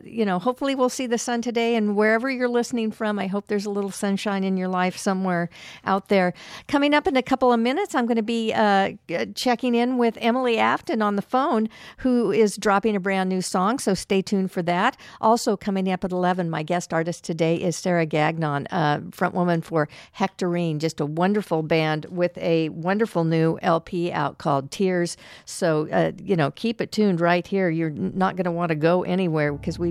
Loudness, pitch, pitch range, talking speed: -23 LUFS, 190 Hz, 170-220 Hz, 215 wpm